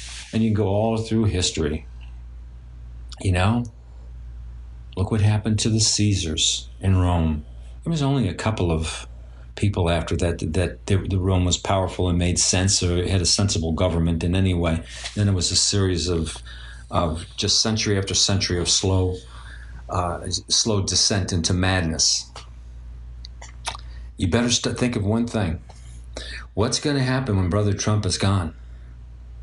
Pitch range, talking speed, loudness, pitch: 60-100 Hz, 160 wpm, -21 LUFS, 90 Hz